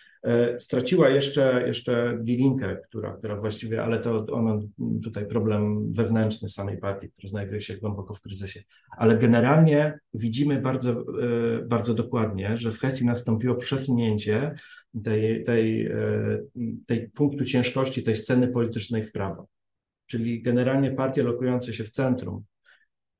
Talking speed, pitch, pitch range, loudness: 125 wpm, 115 Hz, 110-125 Hz, -25 LUFS